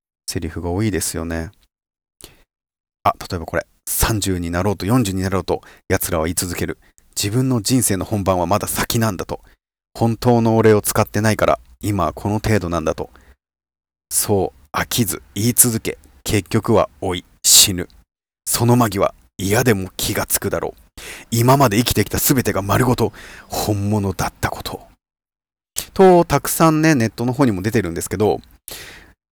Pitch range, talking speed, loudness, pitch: 85-115 Hz, 300 characters per minute, -18 LUFS, 100 Hz